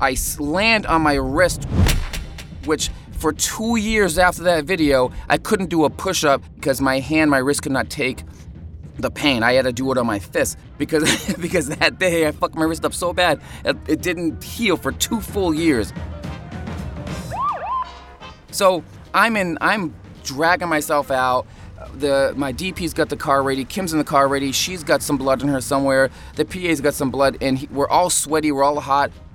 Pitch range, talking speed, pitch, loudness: 135-170 Hz, 185 wpm, 145 Hz, -19 LUFS